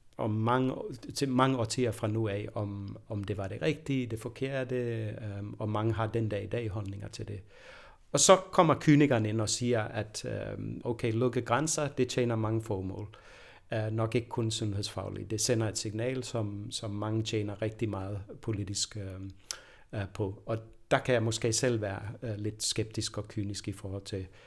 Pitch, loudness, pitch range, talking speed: 110 Hz, -32 LUFS, 105-125 Hz, 185 wpm